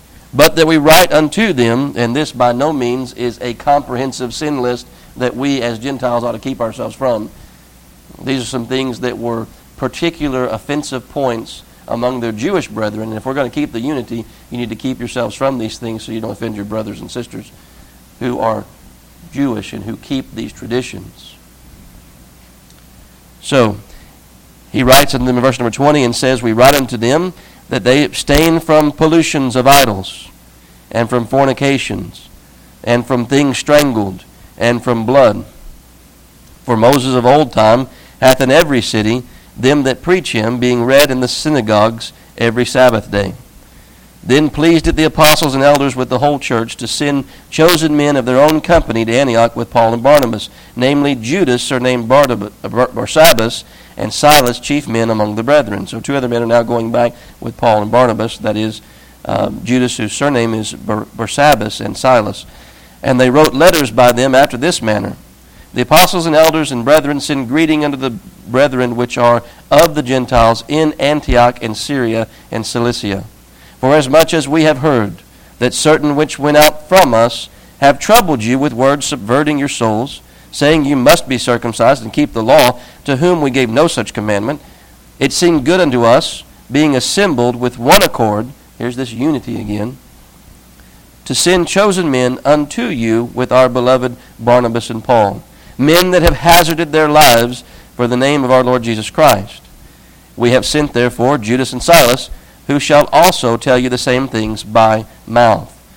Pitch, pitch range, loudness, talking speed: 125 Hz, 115-145 Hz, -12 LUFS, 175 wpm